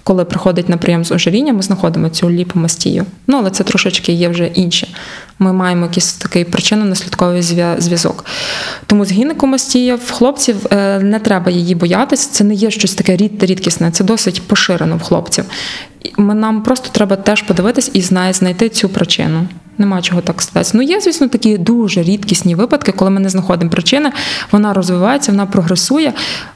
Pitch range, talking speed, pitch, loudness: 180-220 Hz, 170 wpm, 195 Hz, -12 LUFS